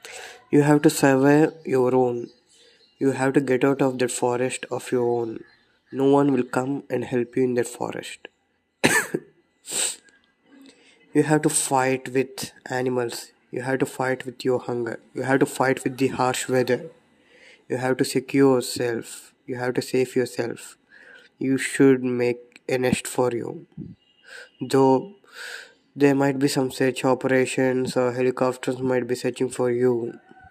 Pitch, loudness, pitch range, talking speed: 130 Hz, -23 LUFS, 125-140 Hz, 155 wpm